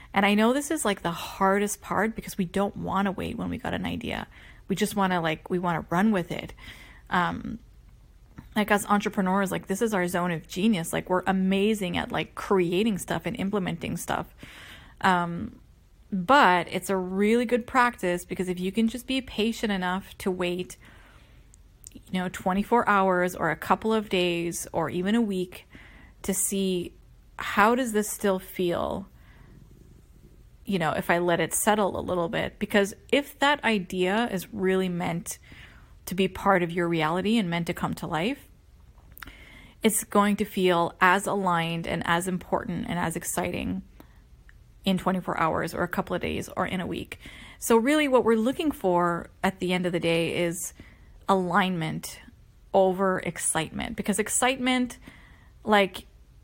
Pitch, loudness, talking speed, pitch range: 190 Hz, -26 LUFS, 170 wpm, 180-210 Hz